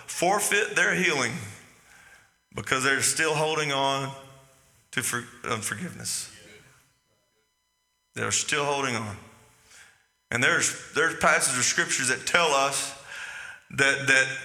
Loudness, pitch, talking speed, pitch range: -24 LUFS, 135 Hz, 110 wpm, 110-140 Hz